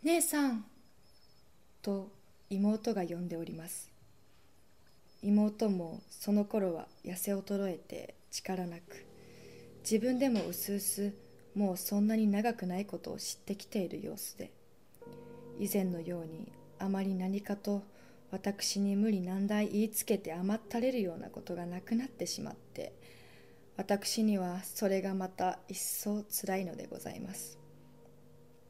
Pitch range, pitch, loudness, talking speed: 180-210 Hz, 200 Hz, -35 LUFS, 255 characters per minute